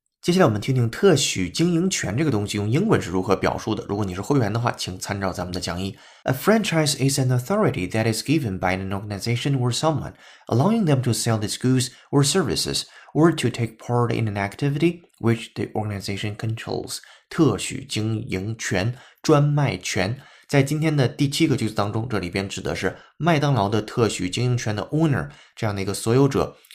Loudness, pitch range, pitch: -23 LUFS, 100-140 Hz, 115 Hz